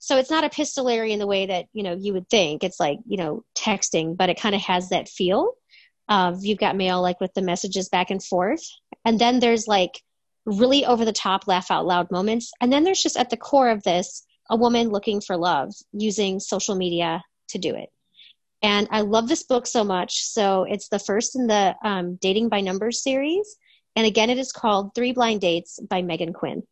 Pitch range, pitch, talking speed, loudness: 185-235 Hz, 210 Hz, 220 wpm, -22 LUFS